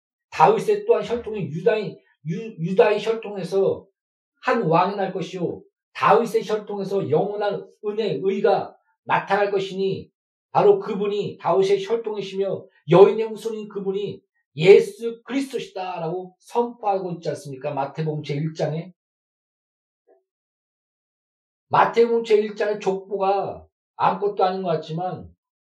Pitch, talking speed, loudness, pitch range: 205 Hz, 270 characters per minute, -22 LUFS, 185-230 Hz